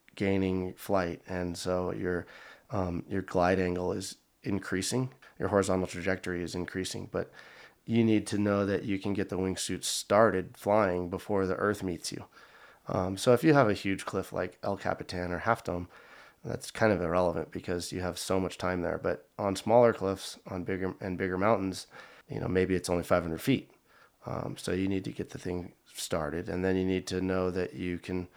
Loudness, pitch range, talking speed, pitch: -31 LUFS, 90-100 Hz, 195 wpm, 95 Hz